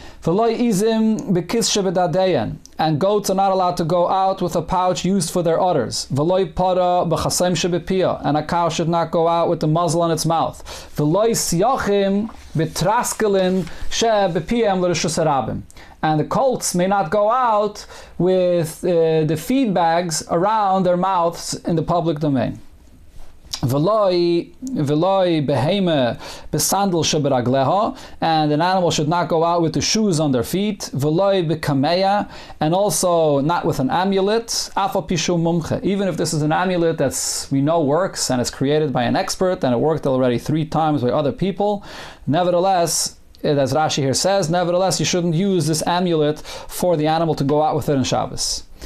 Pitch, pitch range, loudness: 170 Hz, 155-190 Hz, -19 LUFS